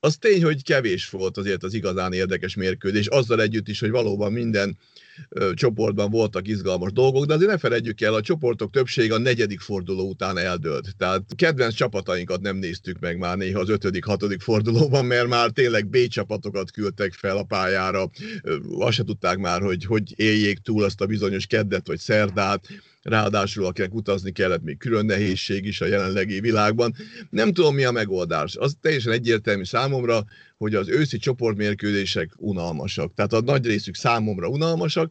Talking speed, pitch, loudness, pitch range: 170 wpm, 105 Hz, -23 LUFS, 95-120 Hz